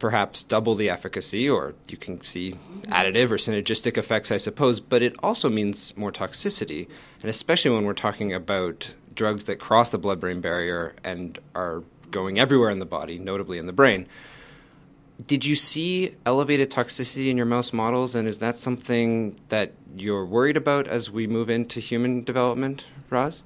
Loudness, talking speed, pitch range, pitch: -24 LUFS, 175 wpm, 100-135 Hz, 115 Hz